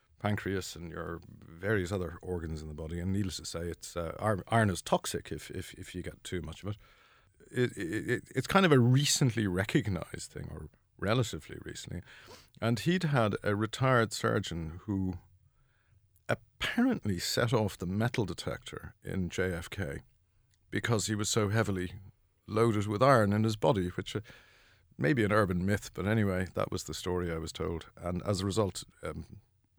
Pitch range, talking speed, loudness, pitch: 90-110 Hz, 175 wpm, -32 LUFS, 100 Hz